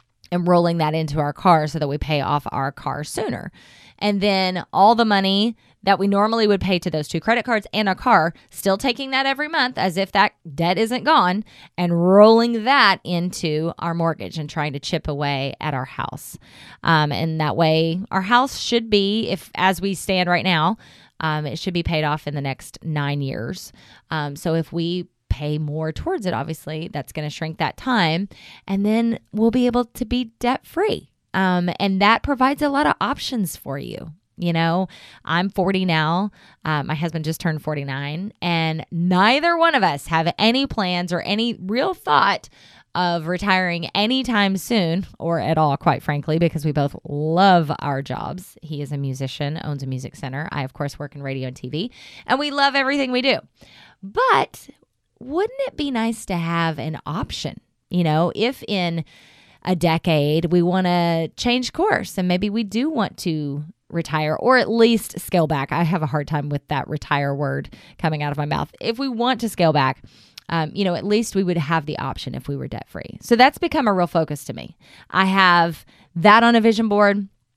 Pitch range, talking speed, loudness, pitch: 155-210 Hz, 200 wpm, -20 LUFS, 175 Hz